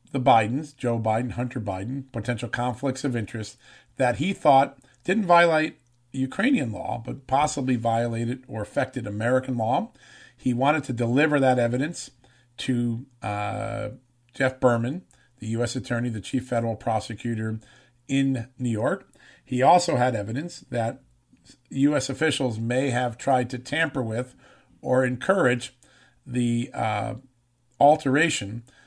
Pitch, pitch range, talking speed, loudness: 125 Hz, 115-135 Hz, 130 wpm, -25 LUFS